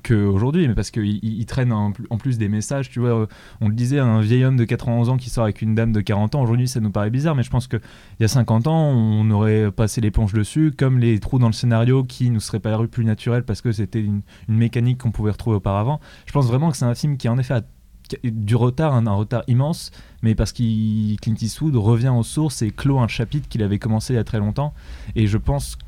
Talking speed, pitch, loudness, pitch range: 265 wpm, 115 Hz, -20 LUFS, 110-125 Hz